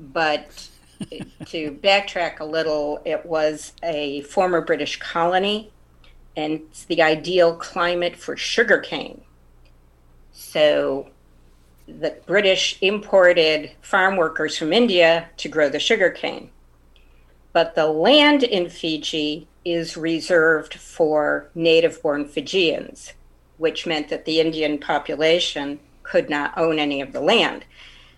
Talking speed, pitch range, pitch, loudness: 115 wpm, 140-170 Hz, 155 Hz, -20 LUFS